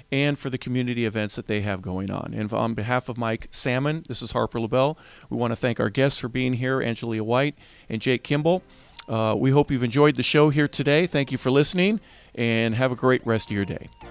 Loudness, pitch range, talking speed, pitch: -23 LUFS, 115-140 Hz, 235 wpm, 125 Hz